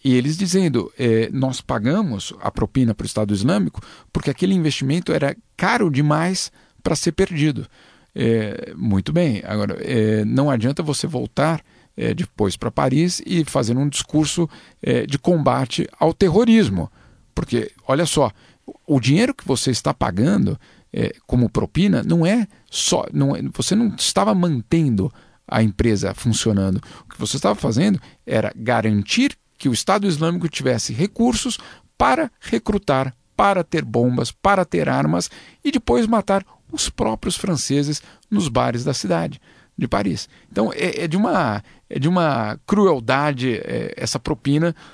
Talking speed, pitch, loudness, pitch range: 150 wpm, 145 Hz, -20 LUFS, 120-175 Hz